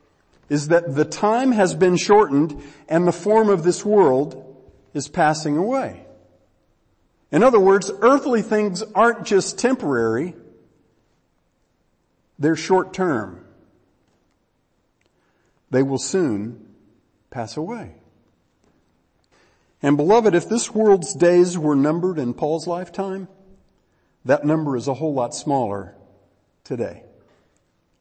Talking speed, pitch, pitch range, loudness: 110 wpm, 150 Hz, 115-190 Hz, -19 LUFS